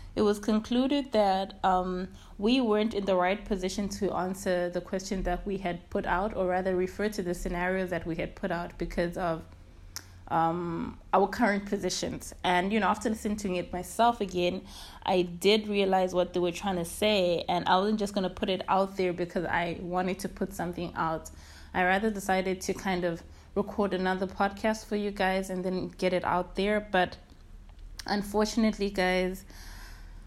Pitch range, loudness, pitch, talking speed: 175-200 Hz, -29 LUFS, 185 Hz, 185 wpm